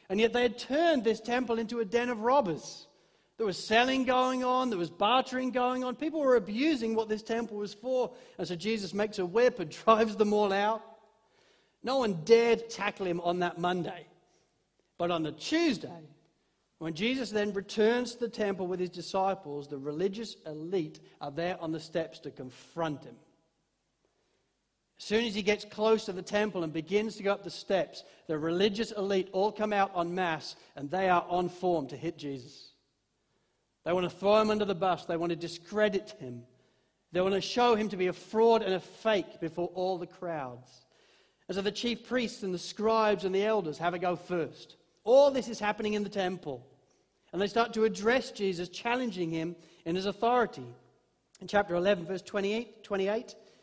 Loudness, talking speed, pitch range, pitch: -30 LUFS, 195 wpm, 175-225 Hz, 200 Hz